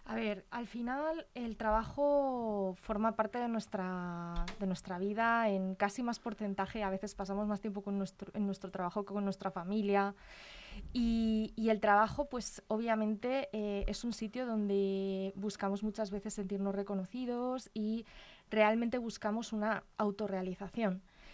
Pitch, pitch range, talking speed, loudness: 210 Hz, 200-225 Hz, 145 wpm, -36 LUFS